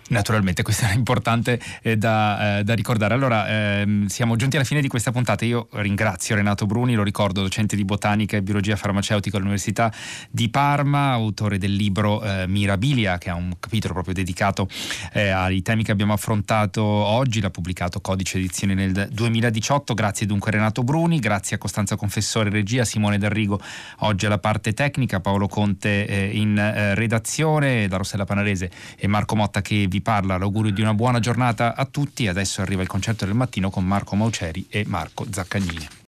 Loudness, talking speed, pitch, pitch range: -22 LUFS, 180 wpm, 105 Hz, 100-115 Hz